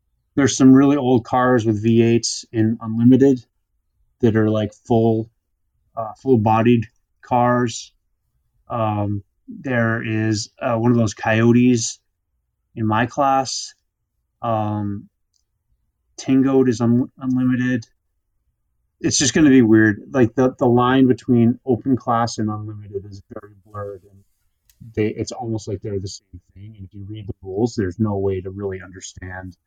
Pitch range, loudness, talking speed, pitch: 100-125 Hz, -18 LUFS, 145 wpm, 110 Hz